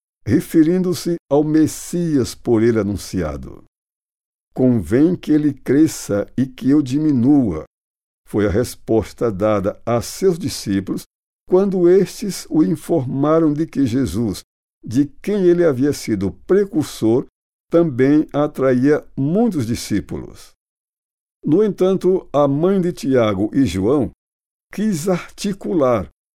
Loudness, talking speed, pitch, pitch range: -18 LUFS, 110 wpm, 145 Hz, 115-175 Hz